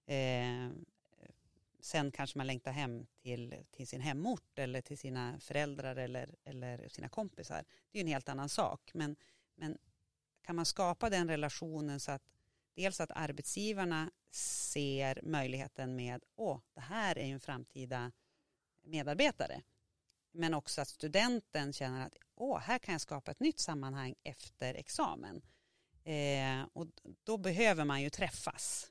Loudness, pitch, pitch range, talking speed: -39 LUFS, 145 Hz, 130-165 Hz, 145 wpm